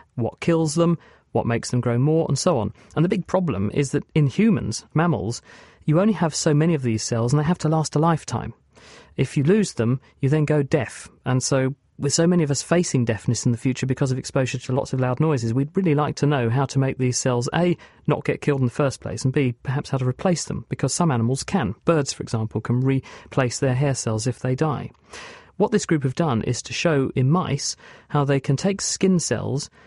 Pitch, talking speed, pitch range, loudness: 140 Hz, 240 wpm, 125-160 Hz, -22 LUFS